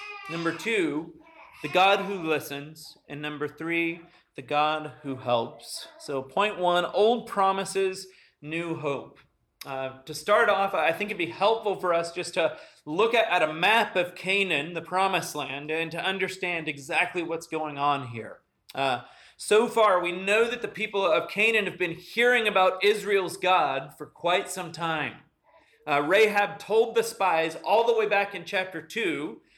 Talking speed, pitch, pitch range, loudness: 170 wpm, 180 Hz, 155-200 Hz, -26 LUFS